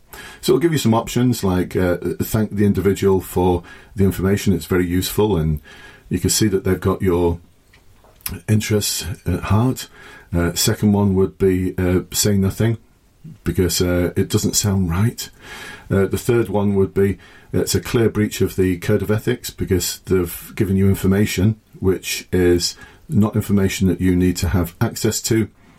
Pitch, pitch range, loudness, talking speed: 95 Hz, 90-105 Hz, -19 LUFS, 170 wpm